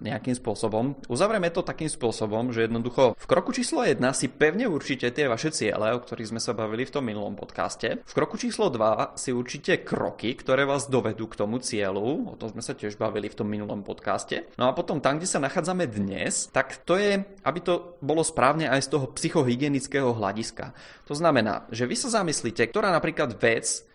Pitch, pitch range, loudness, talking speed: 135 Hz, 115-160 Hz, -26 LUFS, 200 wpm